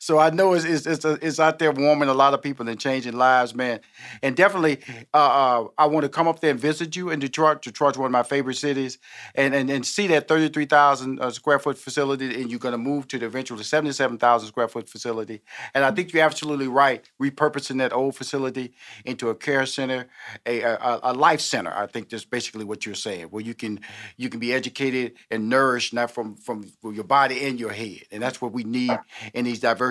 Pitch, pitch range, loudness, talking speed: 130 Hz, 120-145 Hz, -23 LUFS, 225 wpm